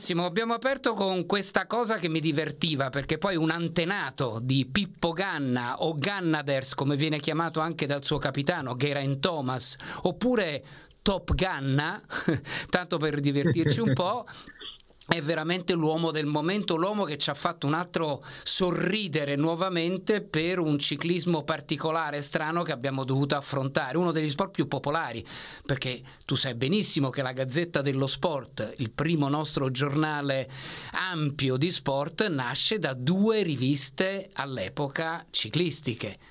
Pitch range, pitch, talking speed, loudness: 140-175 Hz, 155 Hz, 140 wpm, -27 LUFS